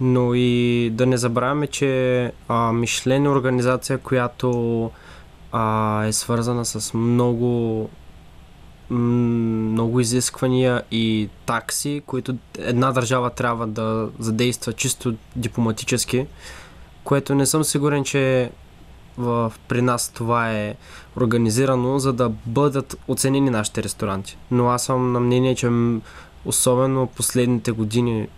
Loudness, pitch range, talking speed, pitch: -21 LUFS, 115-130 Hz, 110 wpm, 120 Hz